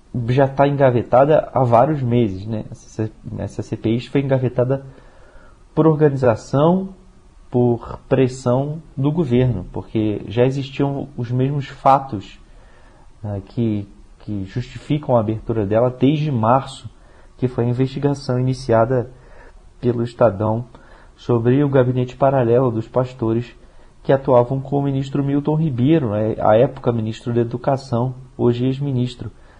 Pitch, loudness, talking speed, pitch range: 125 Hz, -19 LUFS, 120 wpm, 115-135 Hz